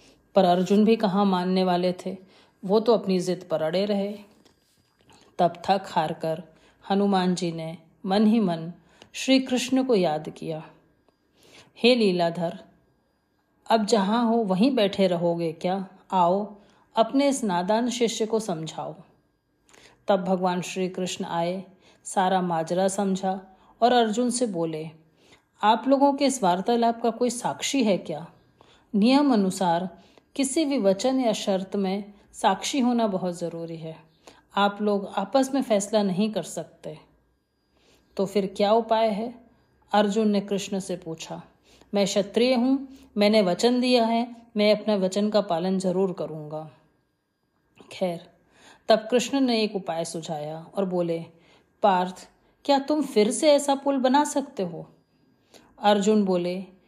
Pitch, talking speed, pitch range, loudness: 200 Hz, 140 wpm, 180-230 Hz, -24 LUFS